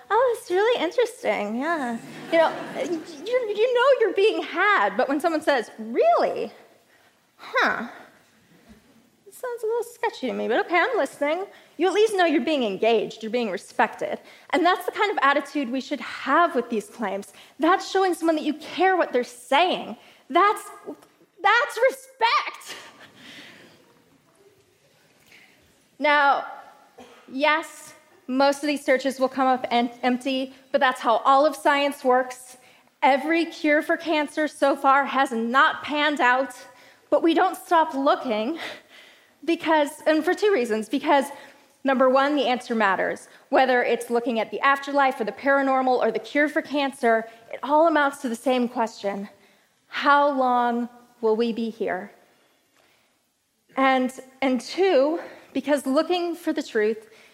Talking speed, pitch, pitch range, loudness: 150 wpm, 285 Hz, 255-335 Hz, -23 LUFS